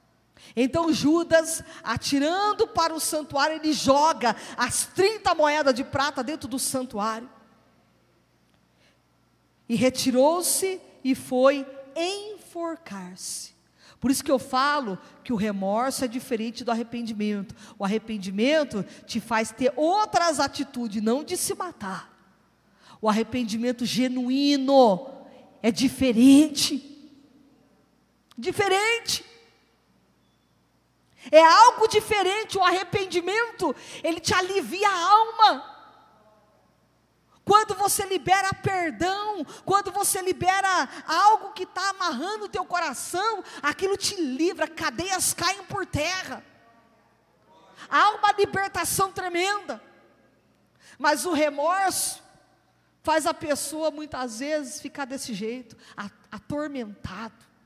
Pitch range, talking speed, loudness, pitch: 255-370 Hz, 100 wpm, -24 LUFS, 300 Hz